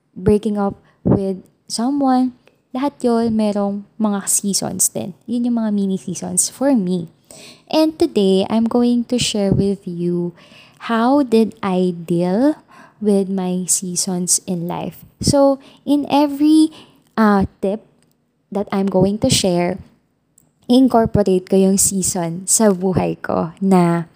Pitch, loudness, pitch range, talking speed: 200 Hz, -17 LUFS, 185-240 Hz, 130 wpm